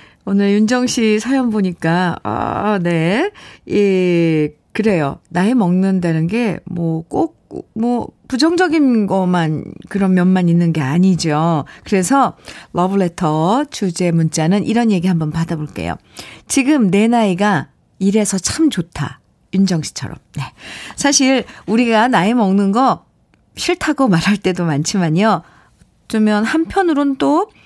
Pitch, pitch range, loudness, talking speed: 200 Hz, 175-235 Hz, -16 LUFS, 245 characters per minute